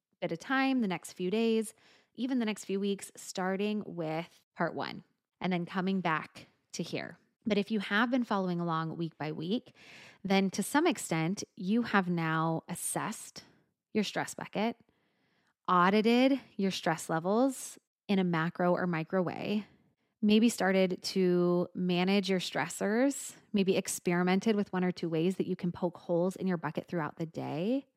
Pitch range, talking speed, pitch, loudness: 175-215 Hz, 165 wpm, 190 Hz, -32 LUFS